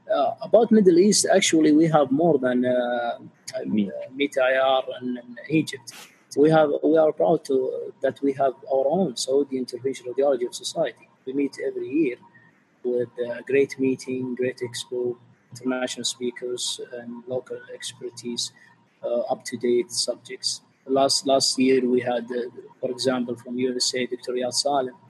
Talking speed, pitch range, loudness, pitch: 155 wpm, 125-155 Hz, -23 LUFS, 130 Hz